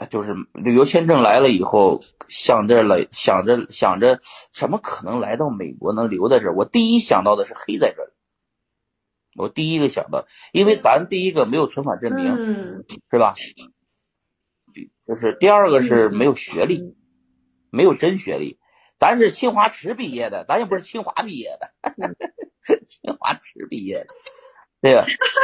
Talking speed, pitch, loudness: 235 characters per minute, 210 Hz, -18 LUFS